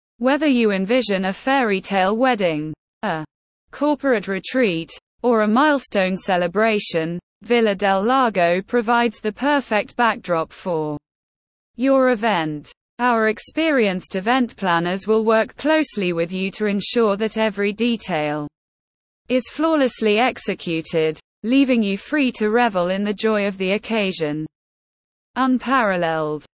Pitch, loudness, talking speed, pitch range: 215 Hz, -20 LUFS, 120 wpm, 185-245 Hz